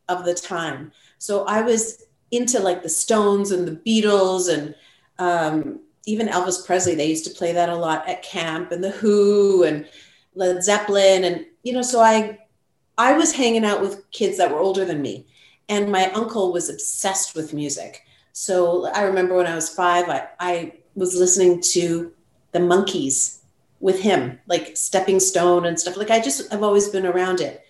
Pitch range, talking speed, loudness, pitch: 170-205 Hz, 185 wpm, -20 LUFS, 180 Hz